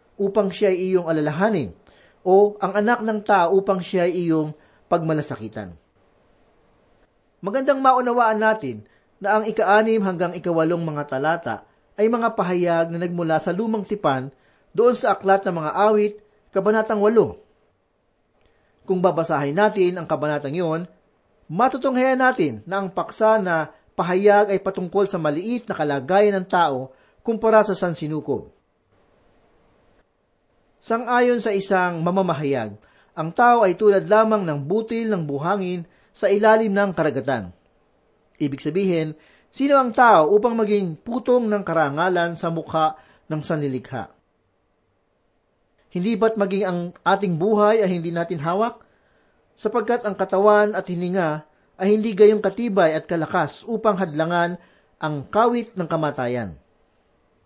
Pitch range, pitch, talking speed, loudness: 160-215 Hz, 190 Hz, 125 wpm, -21 LUFS